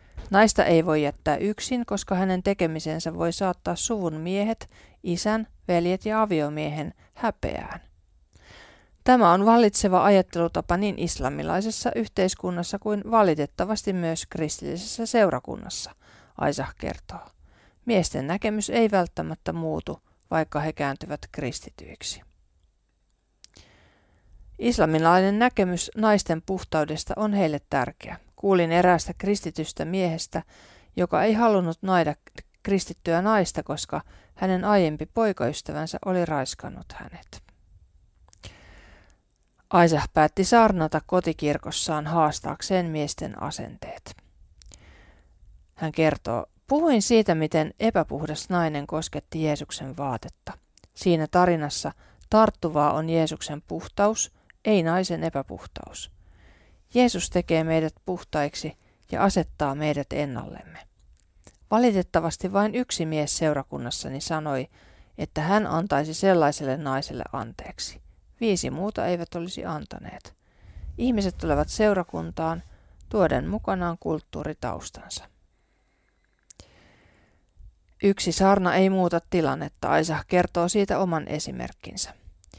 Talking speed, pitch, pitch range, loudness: 95 wpm, 165 Hz, 140-190 Hz, -25 LUFS